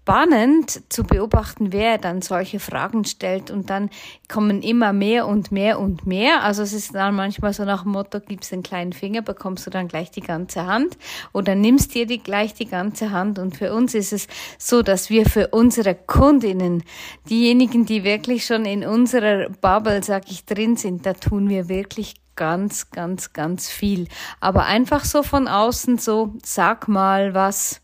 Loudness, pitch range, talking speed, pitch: -20 LUFS, 190-225 Hz, 180 wpm, 205 Hz